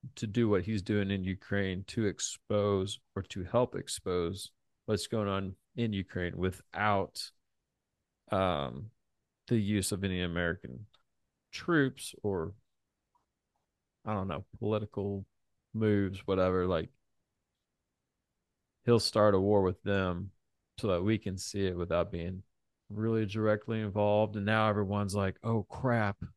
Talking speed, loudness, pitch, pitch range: 130 wpm, -32 LUFS, 100 Hz, 95-110 Hz